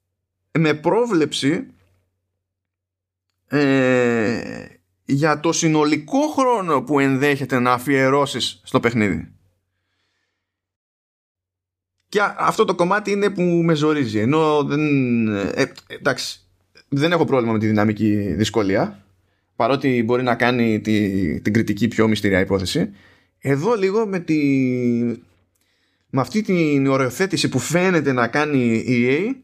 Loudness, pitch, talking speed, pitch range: -19 LUFS, 120 Hz, 115 wpm, 100-150 Hz